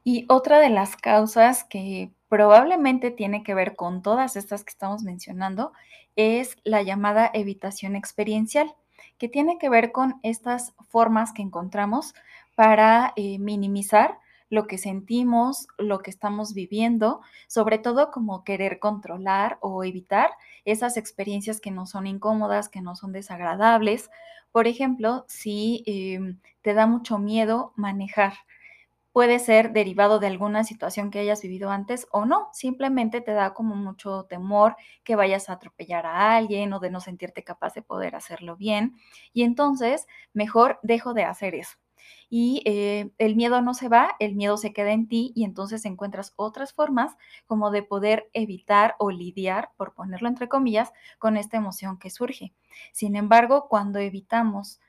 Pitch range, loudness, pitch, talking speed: 200-235 Hz, -23 LUFS, 215 Hz, 155 wpm